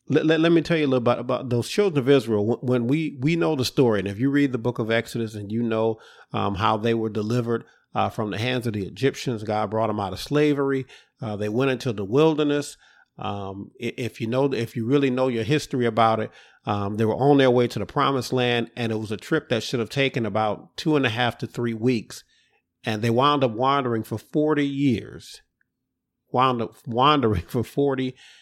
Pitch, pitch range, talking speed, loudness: 125 Hz, 110-140 Hz, 230 wpm, -23 LUFS